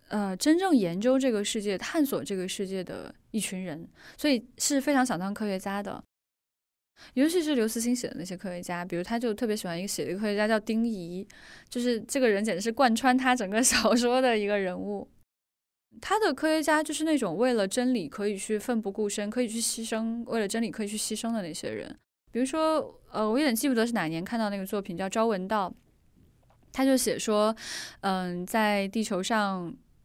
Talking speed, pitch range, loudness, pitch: 305 characters per minute, 200-250 Hz, -28 LUFS, 220 Hz